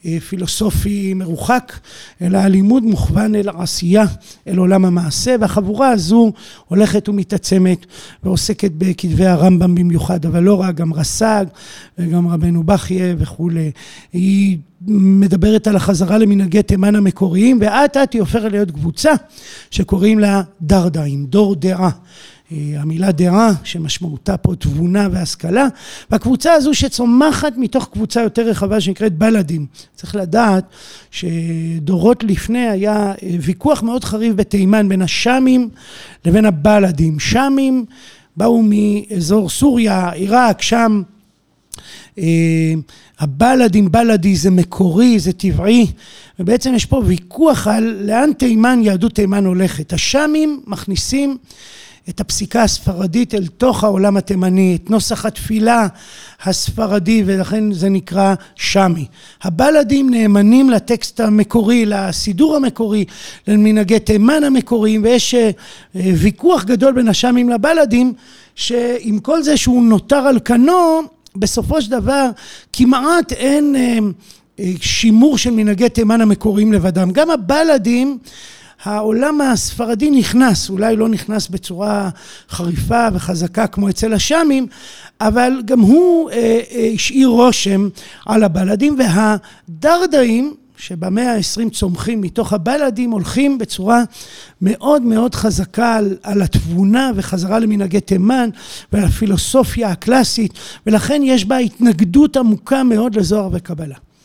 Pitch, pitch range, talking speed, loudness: 210 Hz, 190-240 Hz, 115 wpm, -14 LUFS